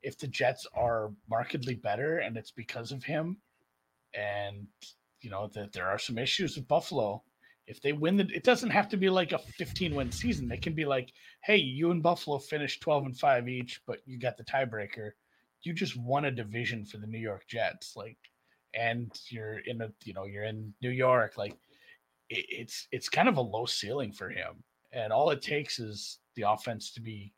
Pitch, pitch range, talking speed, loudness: 120 Hz, 105-145 Hz, 205 wpm, -32 LUFS